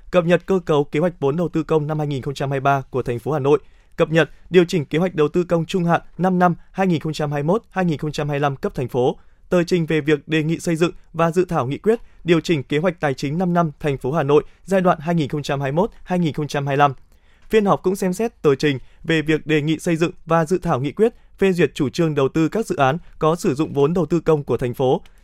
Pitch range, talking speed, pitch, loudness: 145-180 Hz, 235 wpm, 160 Hz, -20 LUFS